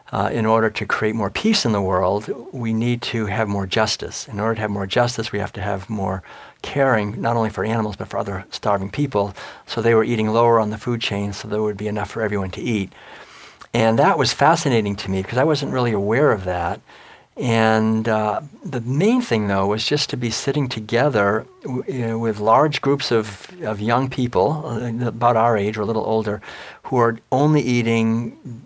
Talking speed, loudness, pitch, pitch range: 215 wpm, -20 LUFS, 115 Hz, 105-120 Hz